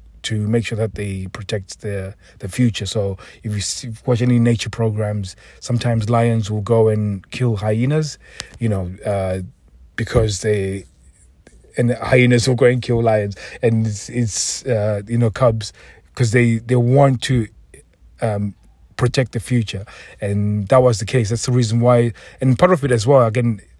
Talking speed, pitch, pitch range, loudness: 175 wpm, 115 Hz, 100-120 Hz, -18 LUFS